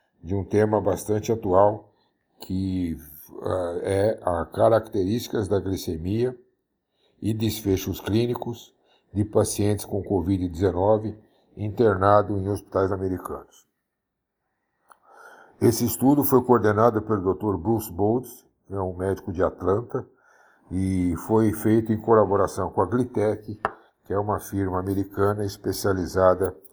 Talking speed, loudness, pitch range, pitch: 110 wpm, -24 LUFS, 95-110 Hz, 105 Hz